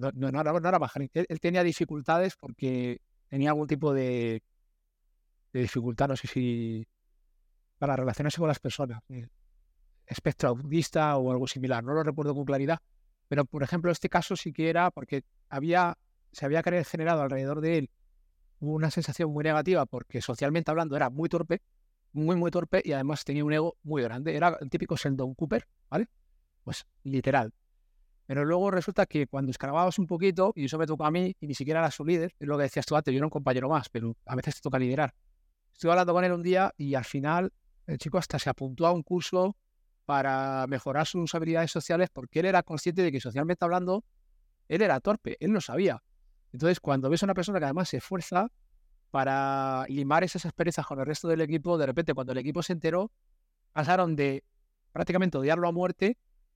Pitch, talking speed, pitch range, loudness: 150 Hz, 195 wpm, 130-170 Hz, -29 LUFS